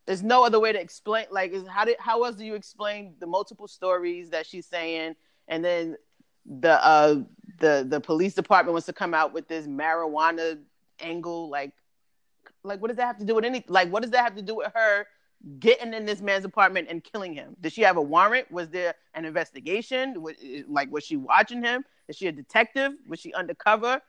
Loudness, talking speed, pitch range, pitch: -25 LUFS, 215 wpm, 165-225 Hz, 190 Hz